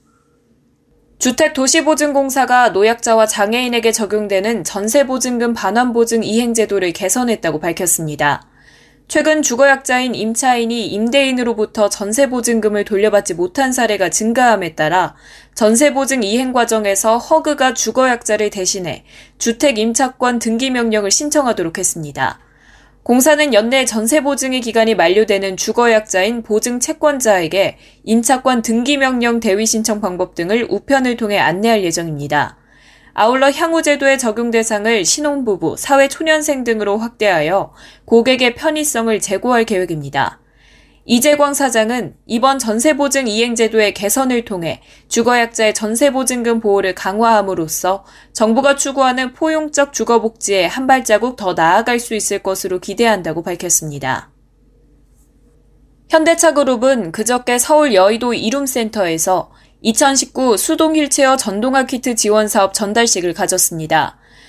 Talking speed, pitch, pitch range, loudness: 325 characters per minute, 230 Hz, 200-265 Hz, -14 LUFS